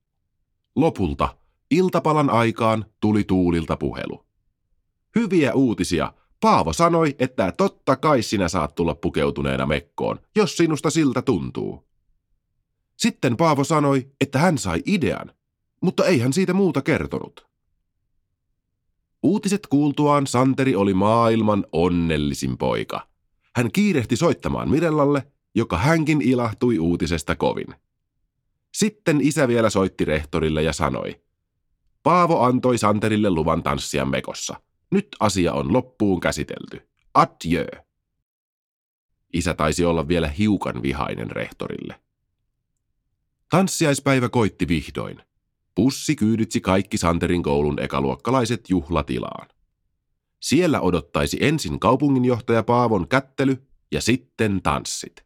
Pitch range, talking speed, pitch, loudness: 85-140 Hz, 105 wpm, 110 Hz, -21 LUFS